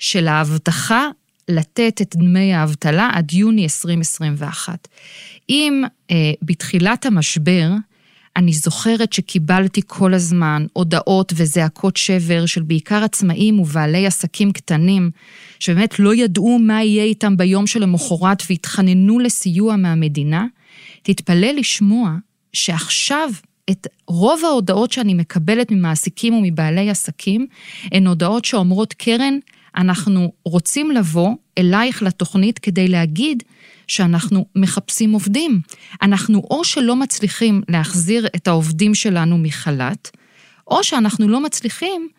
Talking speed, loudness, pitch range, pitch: 110 wpm, -16 LUFS, 175-220 Hz, 190 Hz